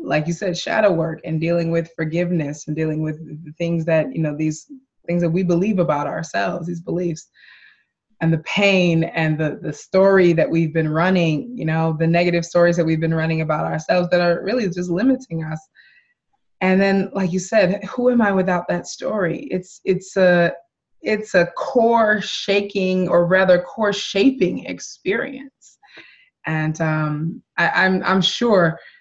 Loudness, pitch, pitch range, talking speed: -19 LUFS, 175 Hz, 160-195 Hz, 170 wpm